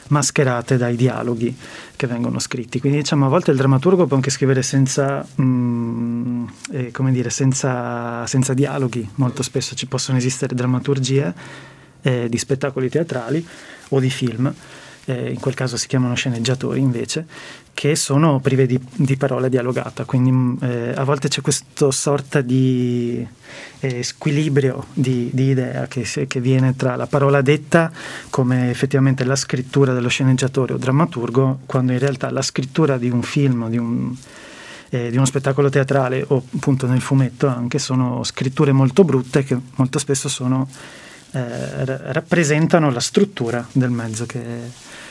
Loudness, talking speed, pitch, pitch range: -19 LUFS, 150 wpm, 130 Hz, 125-140 Hz